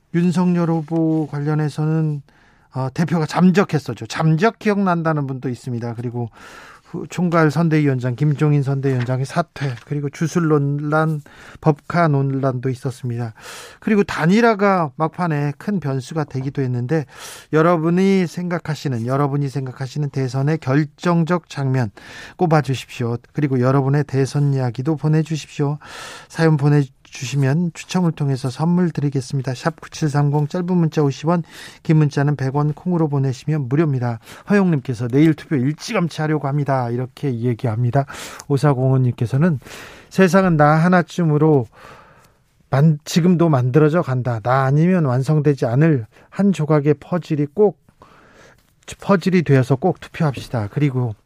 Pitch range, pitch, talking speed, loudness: 135-165 Hz, 150 Hz, 325 characters per minute, -19 LUFS